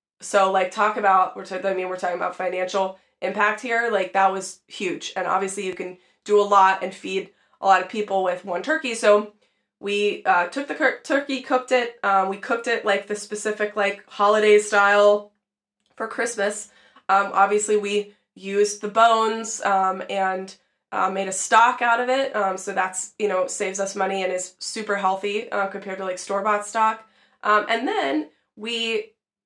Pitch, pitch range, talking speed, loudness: 205 Hz, 190-220 Hz, 185 wpm, -22 LUFS